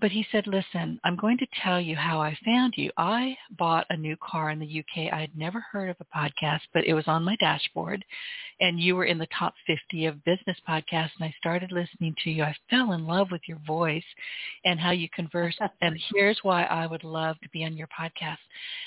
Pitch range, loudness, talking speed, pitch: 160-200 Hz, -28 LUFS, 230 wpm, 170 Hz